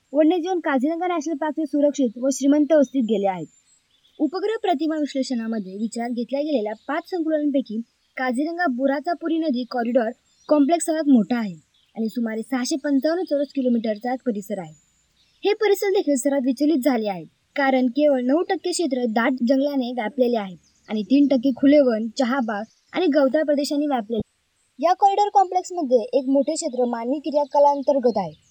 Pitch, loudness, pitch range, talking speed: 275 Hz, -22 LUFS, 240-310 Hz, 150 wpm